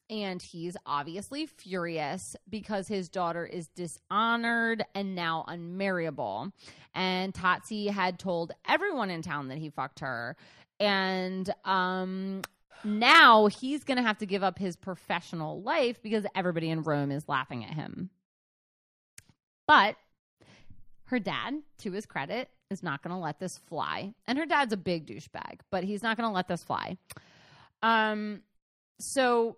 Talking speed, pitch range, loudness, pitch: 140 wpm, 170-215 Hz, -29 LUFS, 190 Hz